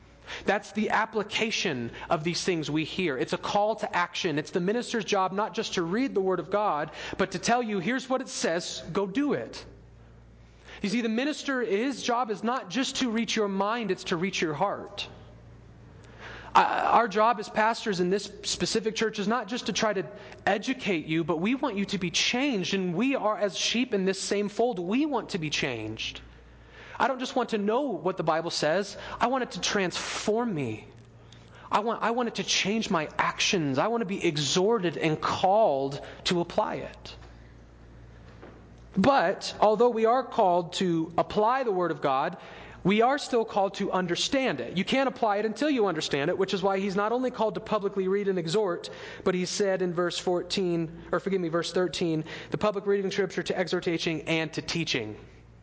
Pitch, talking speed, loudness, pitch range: 195 Hz, 200 wpm, -27 LUFS, 170-225 Hz